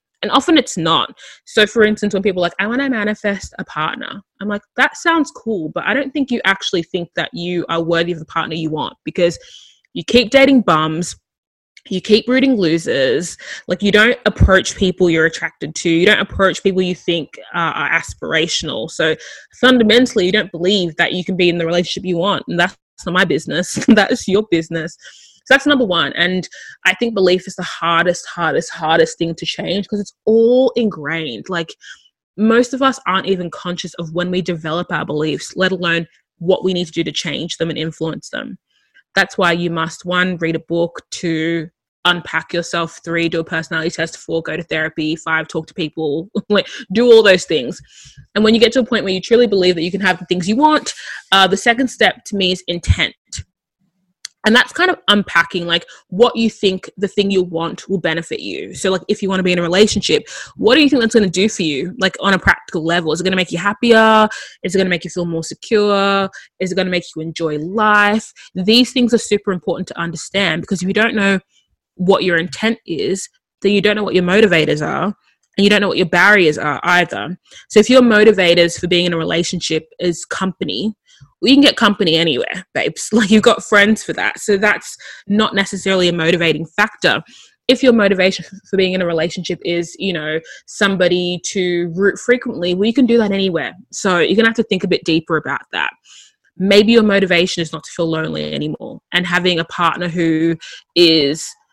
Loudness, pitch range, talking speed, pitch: -15 LUFS, 170-210 Hz, 215 wpm, 185 Hz